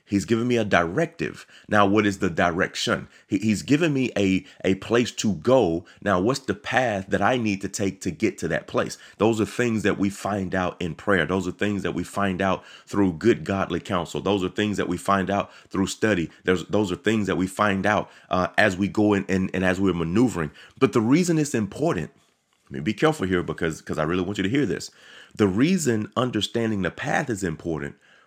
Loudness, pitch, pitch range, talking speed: -24 LUFS, 100 Hz, 90-105 Hz, 225 wpm